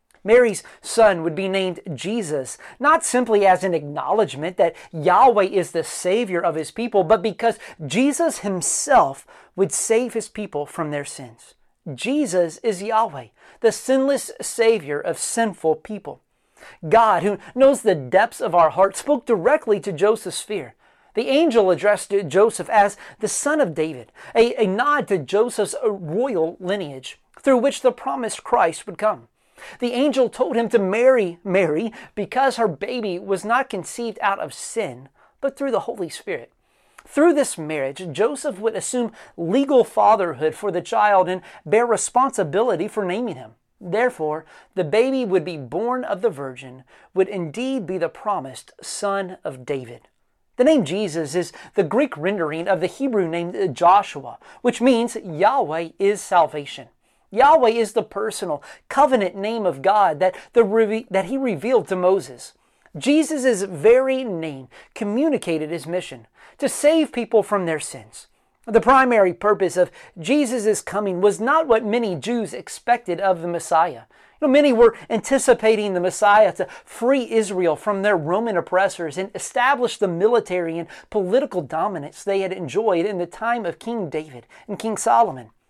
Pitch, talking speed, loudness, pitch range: 205 Hz, 155 wpm, -20 LUFS, 175-235 Hz